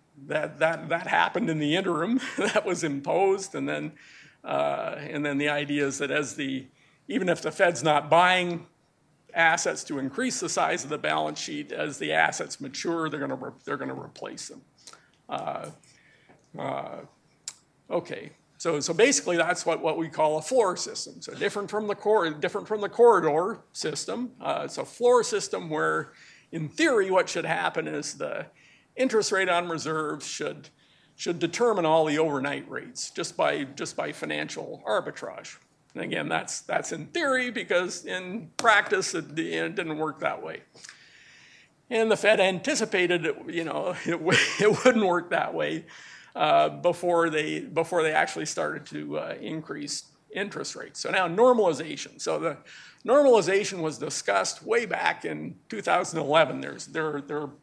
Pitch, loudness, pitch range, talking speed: 170 Hz, -26 LUFS, 150-210 Hz, 165 wpm